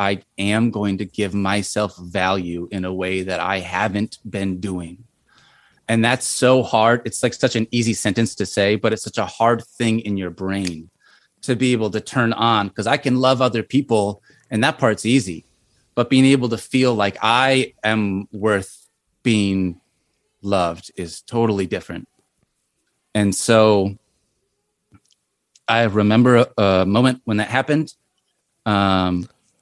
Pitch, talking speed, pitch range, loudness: 110 Hz, 155 wpm, 100-120 Hz, -19 LUFS